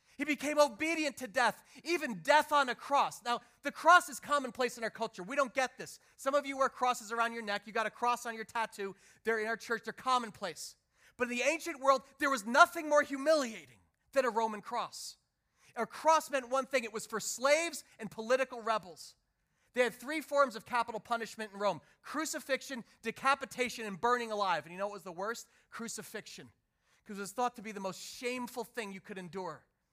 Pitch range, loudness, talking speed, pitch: 215-275 Hz, -33 LUFS, 210 wpm, 240 Hz